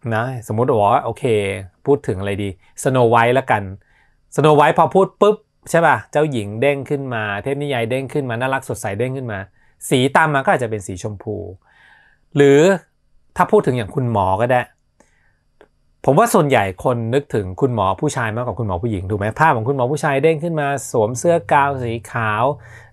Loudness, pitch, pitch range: -18 LUFS, 125 Hz, 110-140 Hz